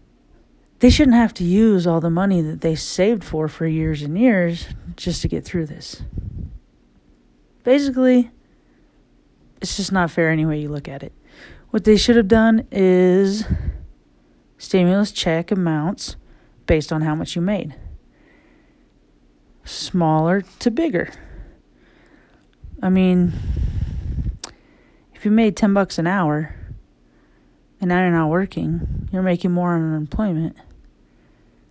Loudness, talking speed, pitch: -19 LUFS, 125 wpm, 165 Hz